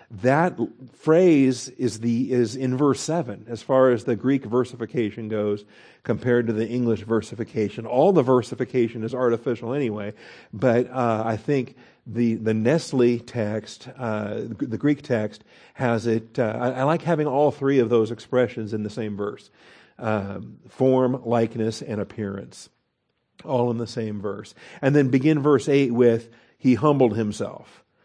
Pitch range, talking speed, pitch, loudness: 110-130 Hz, 155 wpm, 120 Hz, -23 LUFS